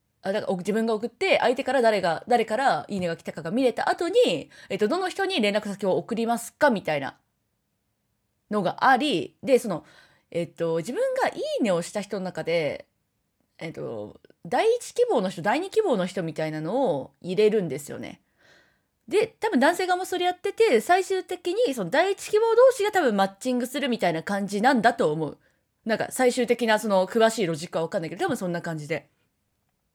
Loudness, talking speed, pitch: -25 LUFS, 365 characters per minute, 230 Hz